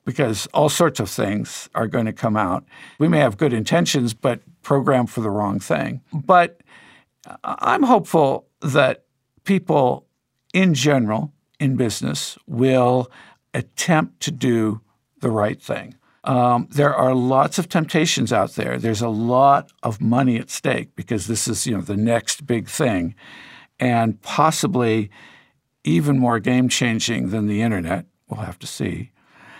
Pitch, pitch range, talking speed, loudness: 120 Hz, 110-140 Hz, 150 wpm, -20 LUFS